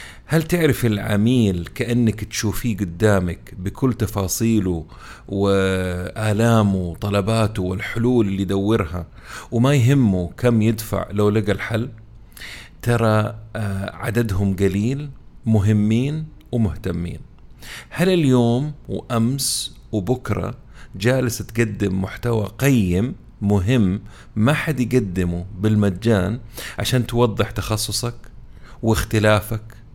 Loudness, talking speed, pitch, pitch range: -20 LUFS, 85 wpm, 110 Hz, 100-120 Hz